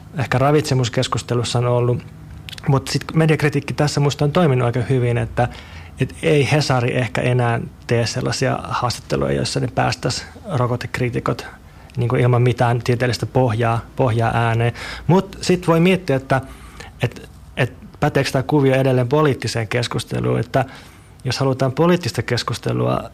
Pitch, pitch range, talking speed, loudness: 125 Hz, 120-140 Hz, 130 wpm, -19 LUFS